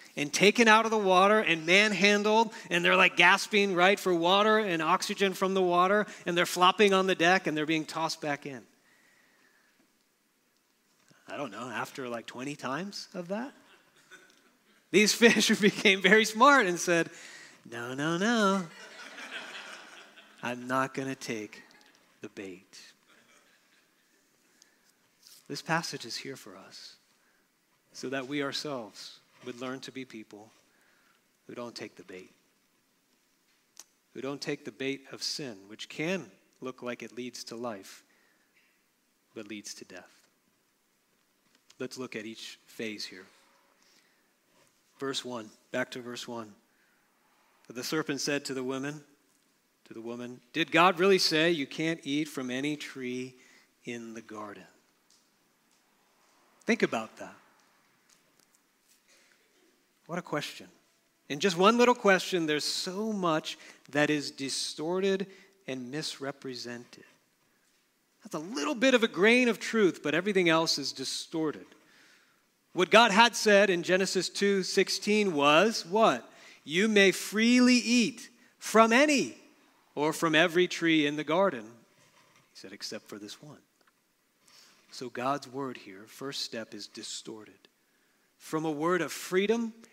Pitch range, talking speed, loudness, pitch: 135-195 Hz, 135 wpm, -27 LUFS, 160 Hz